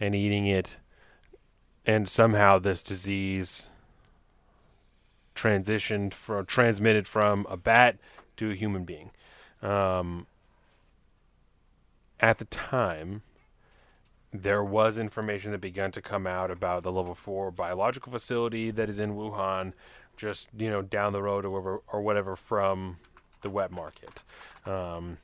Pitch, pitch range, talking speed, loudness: 100 Hz, 95-105 Hz, 130 wpm, -28 LUFS